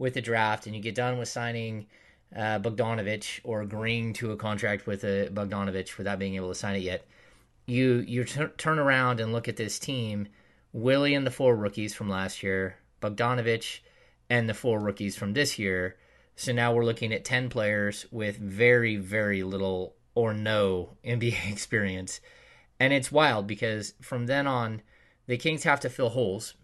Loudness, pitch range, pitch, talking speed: -28 LUFS, 100-120 Hz, 110 Hz, 180 wpm